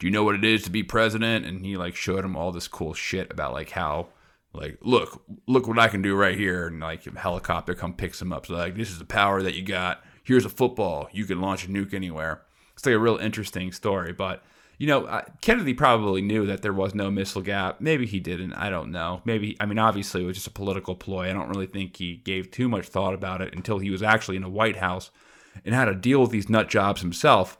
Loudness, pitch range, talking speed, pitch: -25 LUFS, 90-110 Hz, 255 wpm, 95 Hz